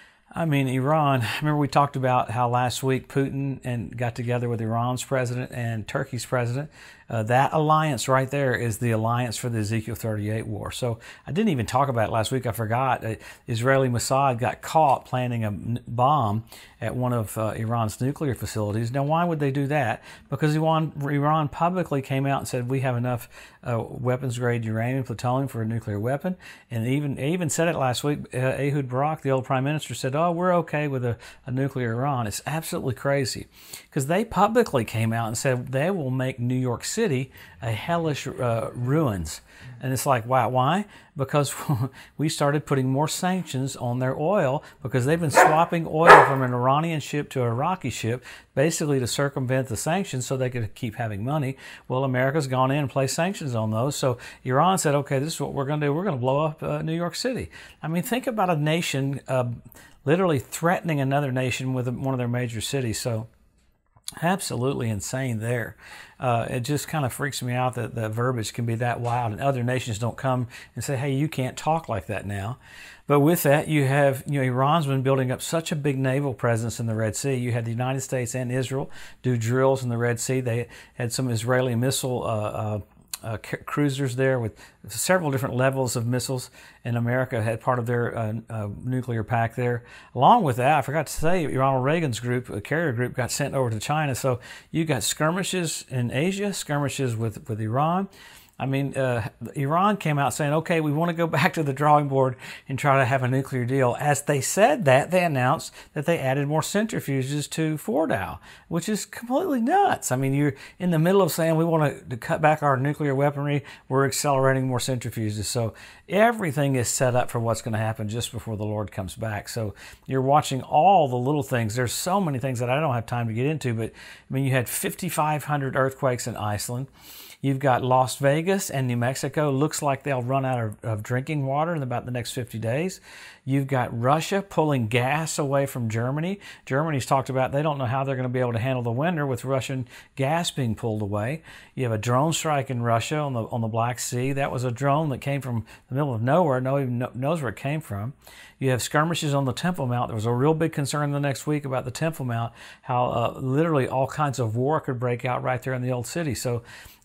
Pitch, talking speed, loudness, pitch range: 130 Hz, 215 wpm, -25 LUFS, 120-150 Hz